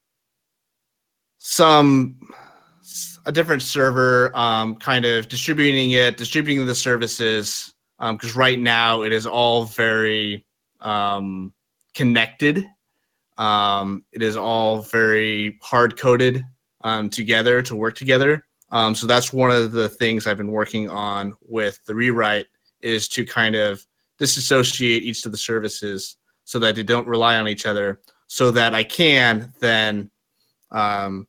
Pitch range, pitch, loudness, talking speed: 110-125 Hz, 115 Hz, -19 LUFS, 135 wpm